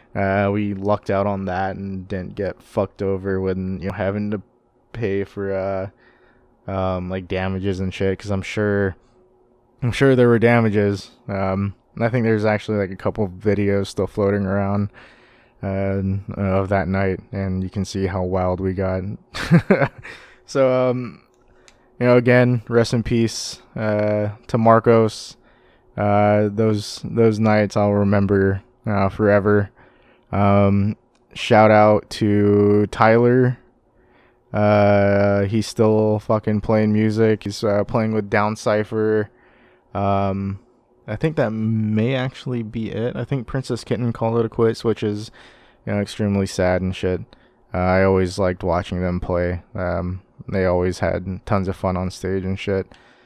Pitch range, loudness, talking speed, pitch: 95-115 Hz, -20 LUFS, 150 wpm, 105 Hz